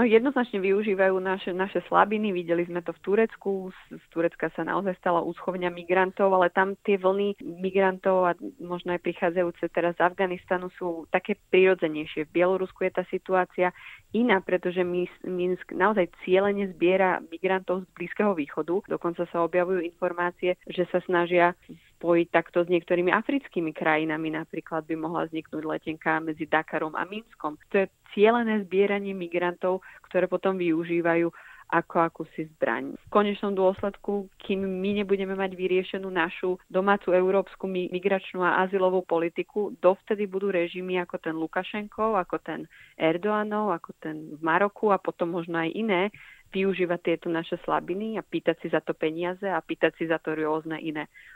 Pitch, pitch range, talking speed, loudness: 180 Hz, 170-195 Hz, 155 wpm, -27 LUFS